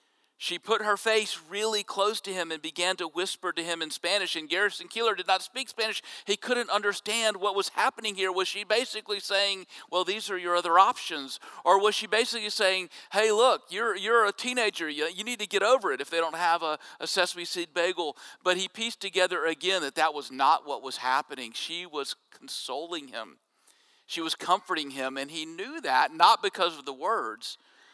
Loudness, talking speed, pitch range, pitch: -27 LUFS, 205 wpm, 175-220 Hz, 195 Hz